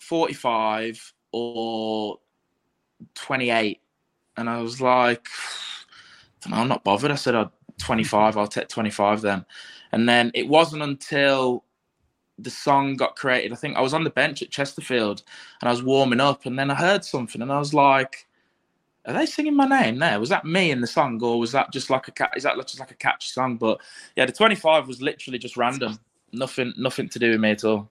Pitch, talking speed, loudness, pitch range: 125 Hz, 205 wpm, -23 LUFS, 115-140 Hz